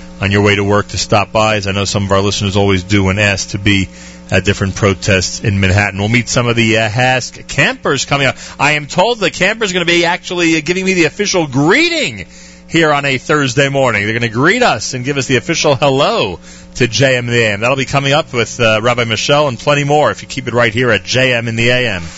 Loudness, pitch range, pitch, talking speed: -12 LUFS, 100-145 Hz, 120 Hz, 260 wpm